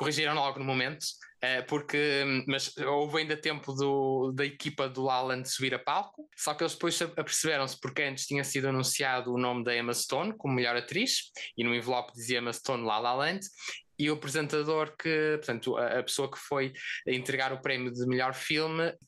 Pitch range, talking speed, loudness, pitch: 130-150 Hz, 185 wpm, -31 LUFS, 135 Hz